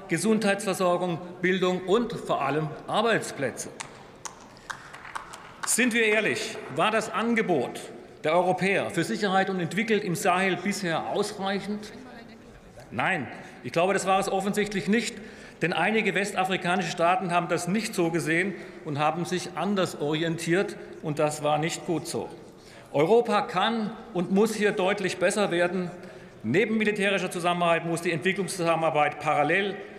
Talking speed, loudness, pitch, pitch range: 130 wpm, -26 LUFS, 185 Hz, 170-205 Hz